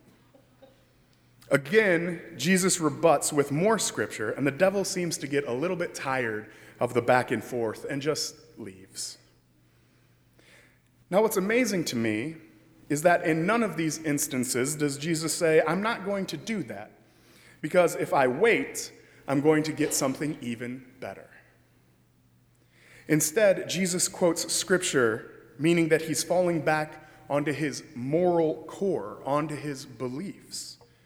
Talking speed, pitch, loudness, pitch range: 140 wpm, 155 Hz, -27 LUFS, 125-175 Hz